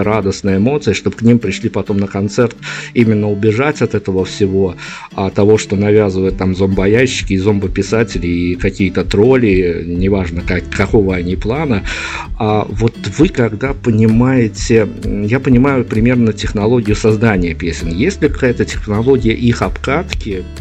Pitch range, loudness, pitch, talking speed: 95-115 Hz, -14 LUFS, 105 Hz, 135 wpm